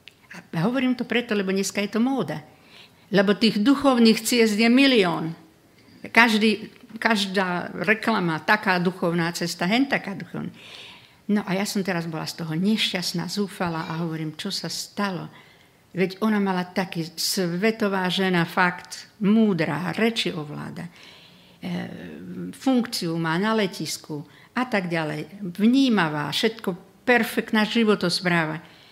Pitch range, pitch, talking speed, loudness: 170-220 Hz, 195 Hz, 125 wpm, -23 LUFS